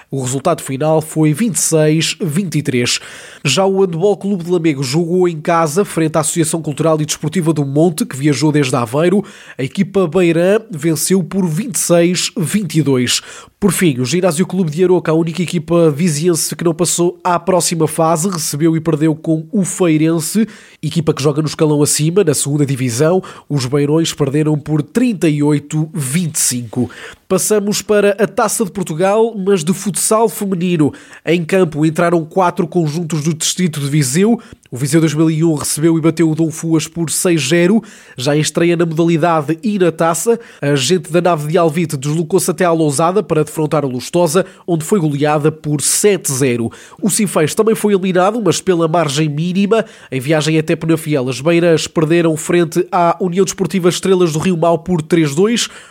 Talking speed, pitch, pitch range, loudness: 165 wpm, 170 Hz, 155-185 Hz, -14 LUFS